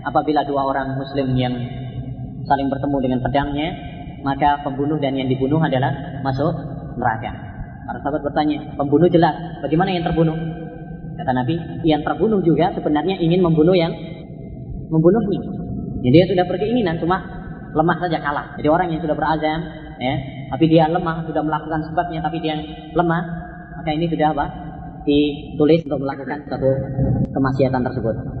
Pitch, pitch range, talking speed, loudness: 150 Hz, 140-165 Hz, 145 wpm, -20 LUFS